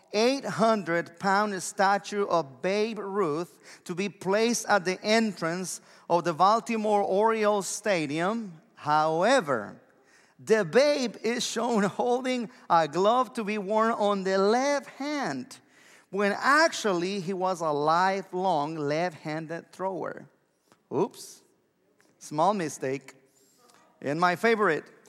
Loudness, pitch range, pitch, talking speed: -27 LUFS, 170-220 Hz, 200 Hz, 110 wpm